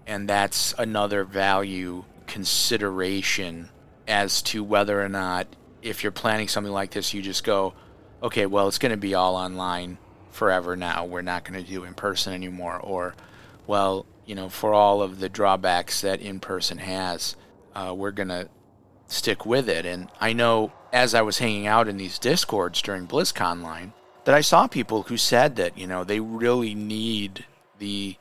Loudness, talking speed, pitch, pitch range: -24 LUFS, 180 wpm, 100 Hz, 90-105 Hz